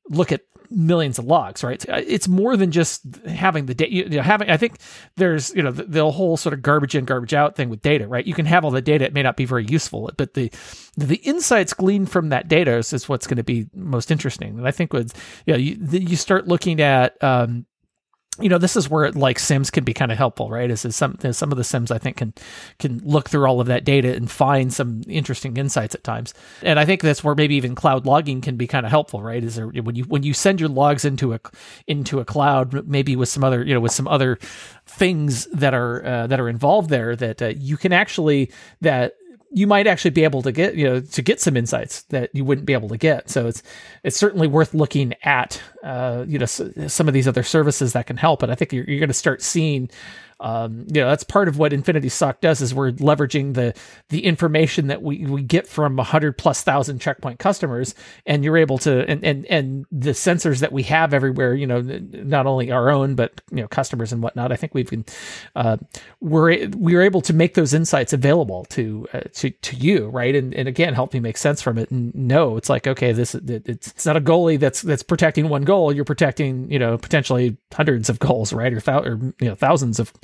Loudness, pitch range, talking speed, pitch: -19 LUFS, 125-160 Hz, 245 wpm, 140 Hz